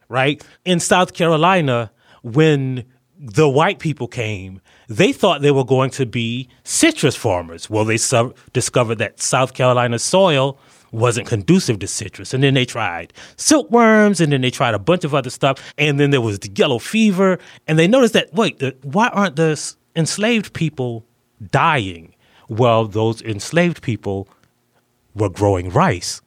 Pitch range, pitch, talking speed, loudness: 115-160 Hz, 130 Hz, 155 wpm, -17 LUFS